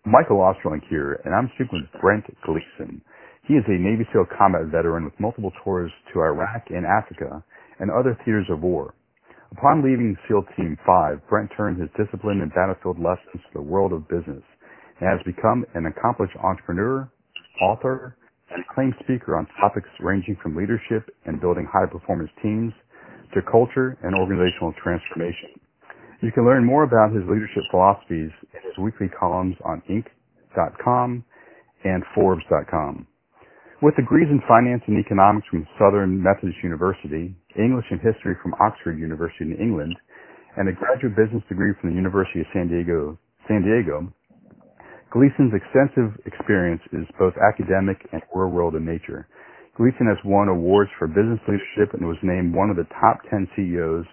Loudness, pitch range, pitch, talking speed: -22 LUFS, 90-115 Hz, 100 Hz, 160 wpm